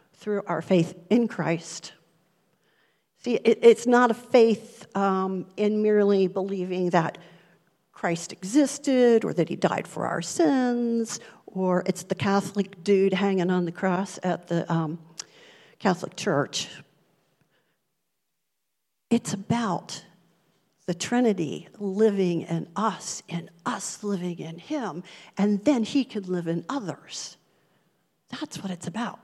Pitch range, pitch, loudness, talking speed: 175-225 Hz, 195 Hz, -25 LUFS, 125 wpm